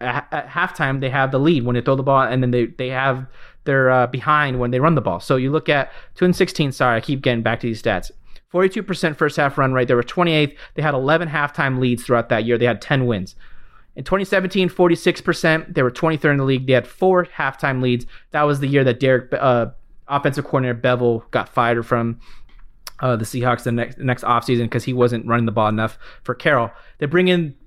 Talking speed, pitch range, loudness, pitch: 225 wpm, 120-150 Hz, -19 LUFS, 130 Hz